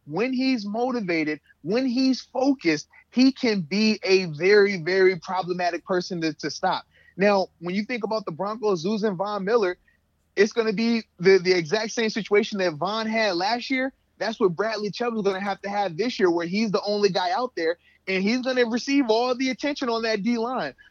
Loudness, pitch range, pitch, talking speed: -24 LUFS, 185-235 Hz, 205 Hz, 205 wpm